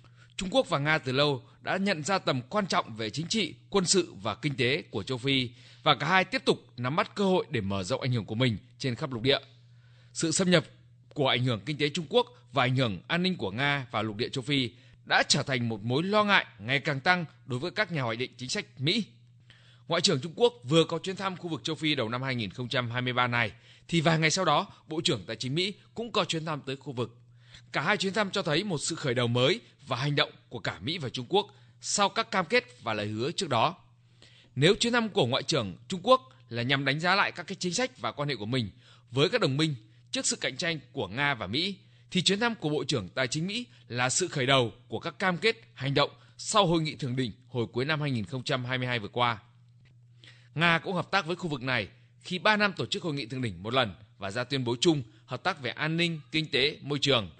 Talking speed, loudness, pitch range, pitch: 255 wpm, -28 LUFS, 120-170 Hz, 135 Hz